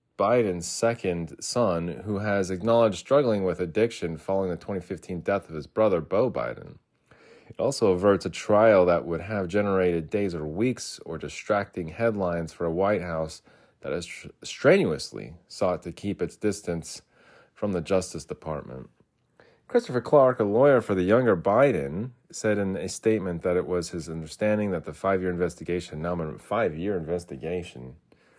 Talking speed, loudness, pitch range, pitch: 160 wpm, -26 LUFS, 85-105 Hz, 90 Hz